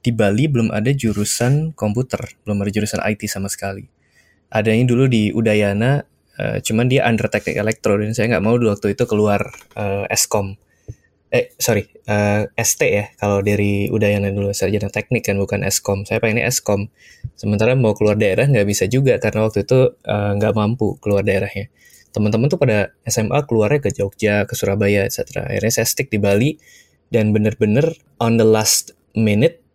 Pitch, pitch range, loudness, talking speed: 110 Hz, 100-120 Hz, -18 LUFS, 170 wpm